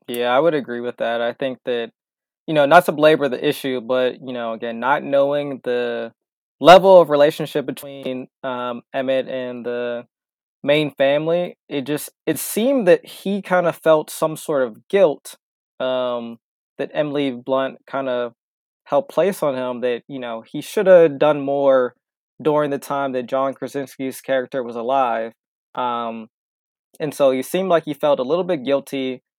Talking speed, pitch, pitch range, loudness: 175 wpm, 135 Hz, 125-150 Hz, -19 LUFS